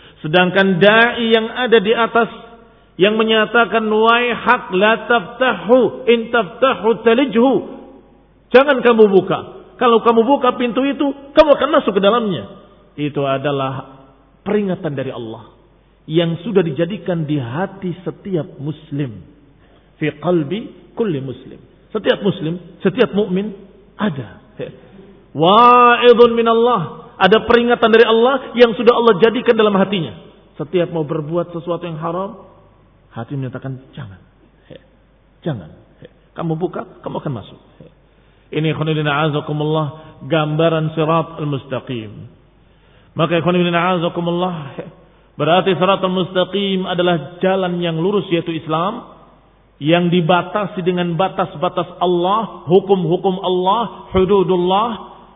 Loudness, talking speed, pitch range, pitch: -16 LUFS, 115 wpm, 160-225 Hz, 185 Hz